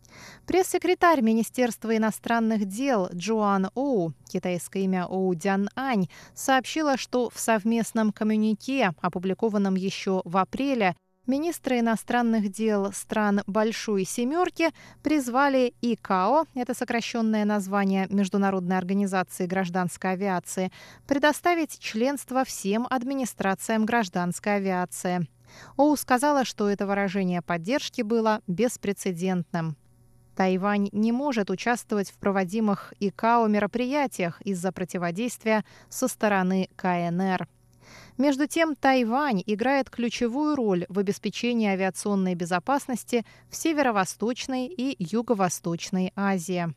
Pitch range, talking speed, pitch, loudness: 190-245 Hz, 100 wpm, 210 Hz, -26 LUFS